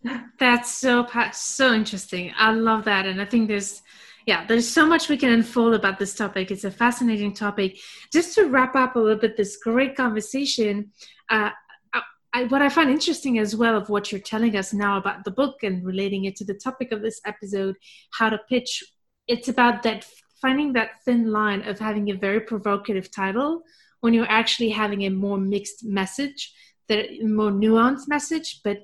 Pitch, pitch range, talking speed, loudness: 220 Hz, 205-250 Hz, 185 wpm, -22 LUFS